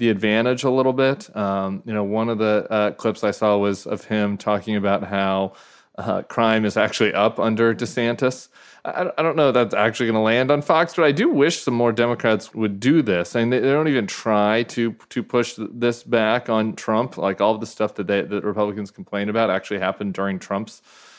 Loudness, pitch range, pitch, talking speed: -21 LUFS, 105-120 Hz, 110 Hz, 225 wpm